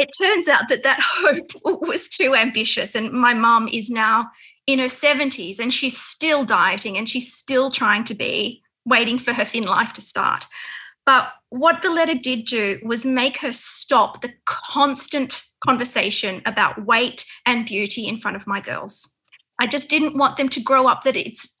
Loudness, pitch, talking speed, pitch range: -19 LUFS, 250 Hz, 185 wpm, 230-280 Hz